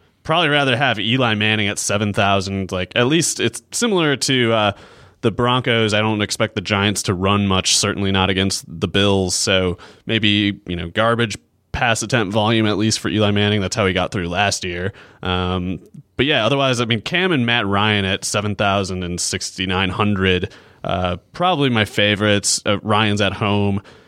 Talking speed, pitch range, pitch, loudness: 180 wpm, 95-115 Hz, 105 Hz, -18 LUFS